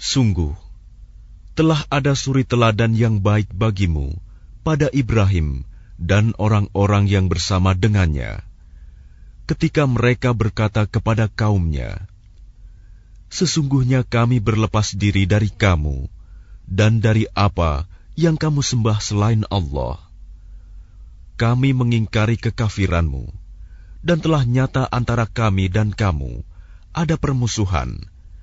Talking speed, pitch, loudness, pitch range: 95 wpm, 105 Hz, -19 LUFS, 95-115 Hz